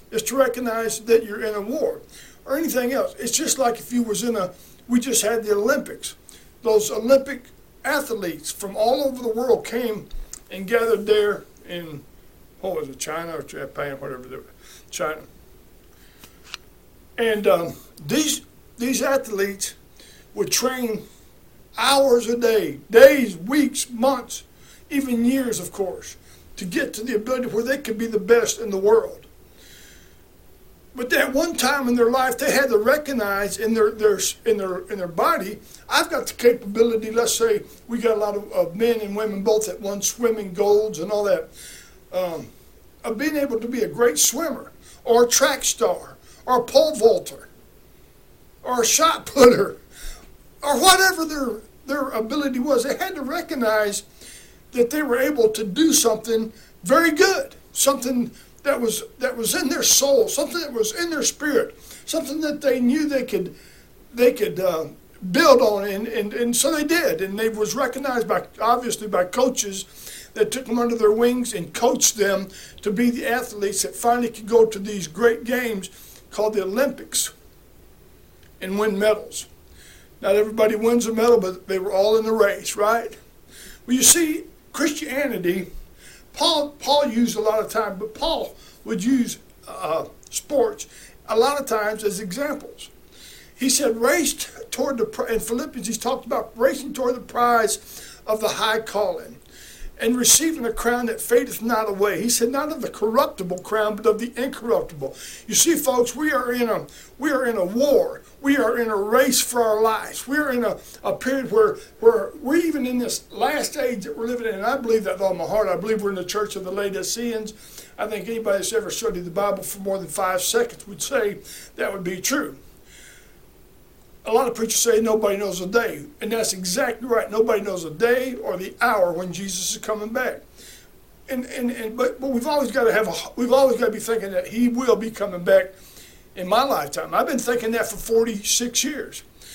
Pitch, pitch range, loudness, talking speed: 230 Hz, 210-265 Hz, -21 LUFS, 185 wpm